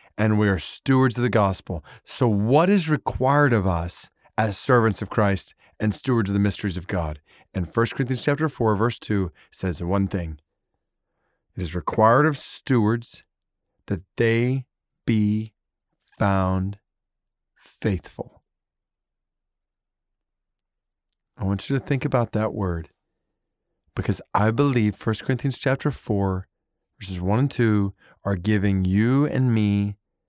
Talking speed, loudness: 135 wpm, -23 LUFS